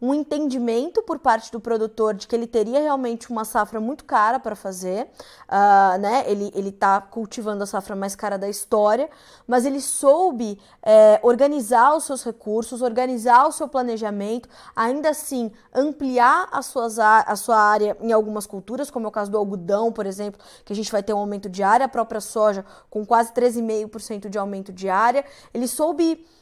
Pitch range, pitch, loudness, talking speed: 210-255 Hz, 225 Hz, -21 LUFS, 185 wpm